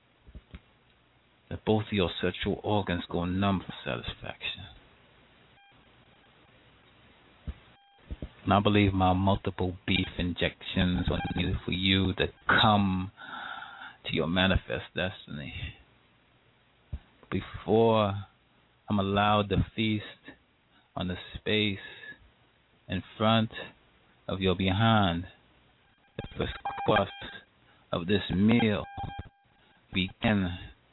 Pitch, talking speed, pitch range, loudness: 95 Hz, 90 wpm, 90-105 Hz, -29 LUFS